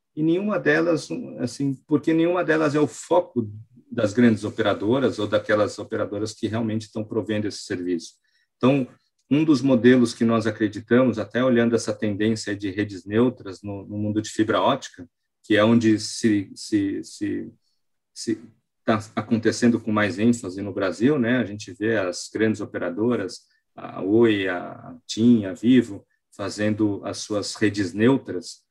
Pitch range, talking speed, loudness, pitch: 105-125 Hz, 150 wpm, -23 LUFS, 115 Hz